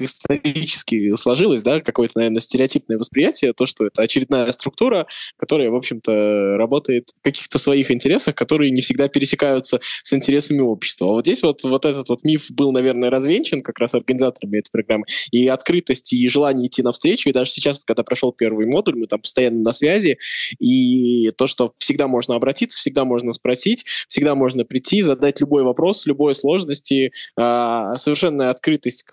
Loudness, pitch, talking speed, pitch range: -18 LUFS, 130 Hz, 165 wpm, 120-140 Hz